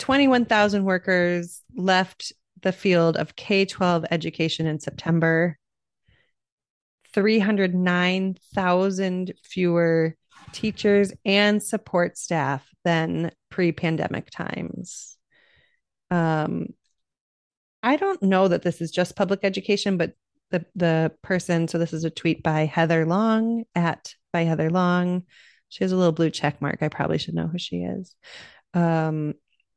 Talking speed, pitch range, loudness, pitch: 120 wpm, 160-195 Hz, -23 LUFS, 175 Hz